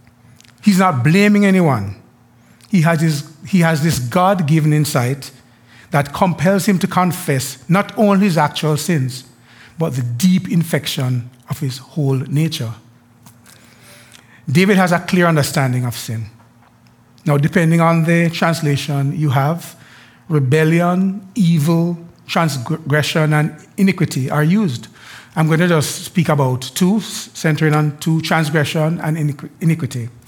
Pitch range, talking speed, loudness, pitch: 130-170 Hz, 125 wpm, -16 LUFS, 155 Hz